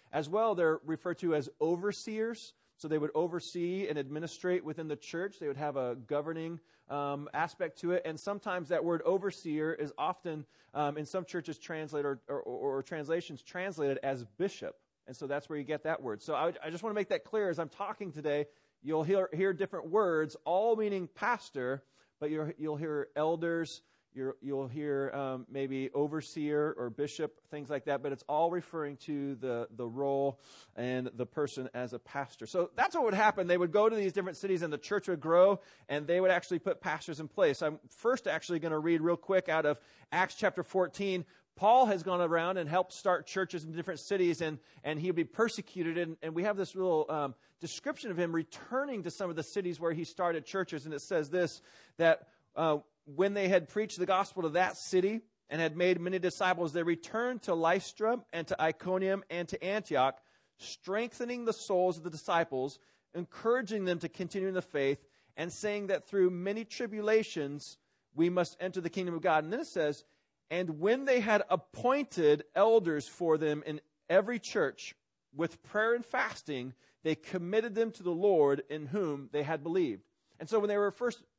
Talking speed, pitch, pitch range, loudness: 200 wpm, 170 Hz, 150-190 Hz, -33 LUFS